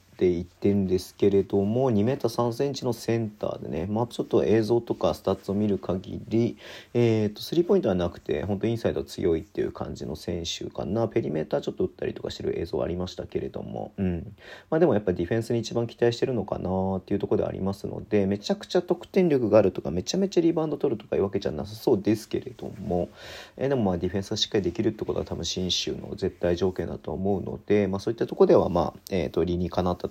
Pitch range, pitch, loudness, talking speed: 90-115 Hz, 100 Hz, -27 LUFS, 510 characters per minute